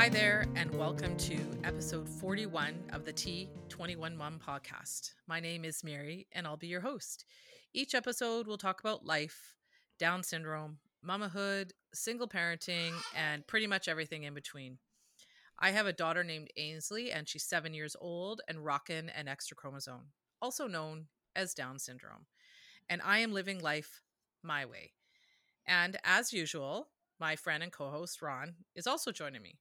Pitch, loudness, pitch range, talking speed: 165 Hz, -37 LUFS, 150-195 Hz, 160 wpm